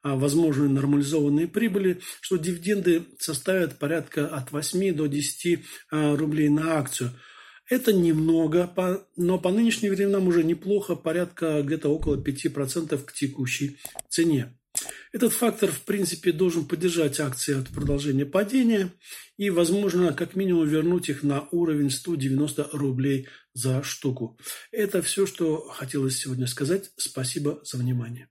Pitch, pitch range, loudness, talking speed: 160 Hz, 145-185 Hz, -25 LUFS, 125 wpm